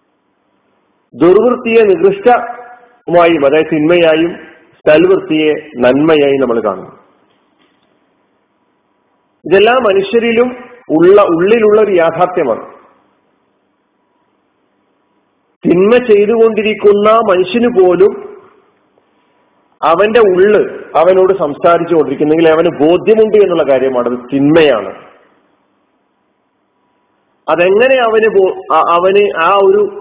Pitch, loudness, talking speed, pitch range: 205 Hz, -9 LUFS, 65 wpm, 165-240 Hz